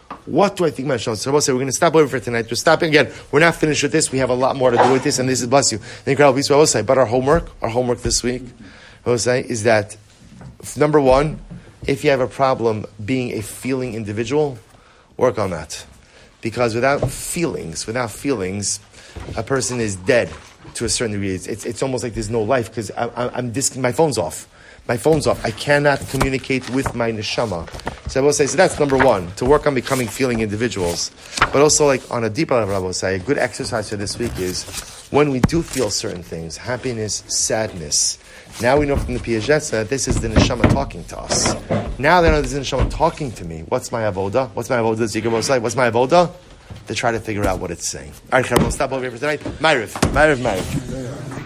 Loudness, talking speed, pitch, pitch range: -19 LUFS, 230 wpm, 125 Hz, 110-135 Hz